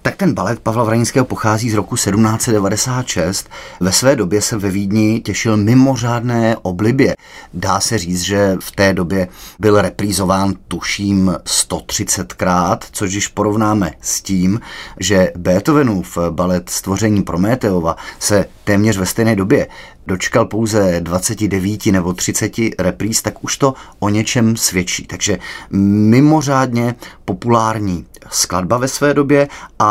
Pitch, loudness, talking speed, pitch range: 105 Hz, -15 LUFS, 130 wpm, 95-115 Hz